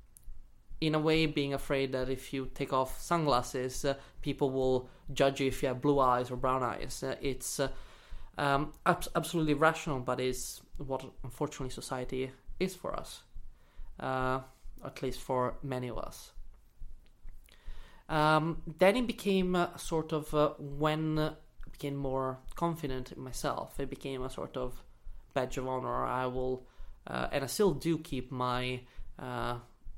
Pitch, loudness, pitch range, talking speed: 135 Hz, -33 LUFS, 130-155 Hz, 160 wpm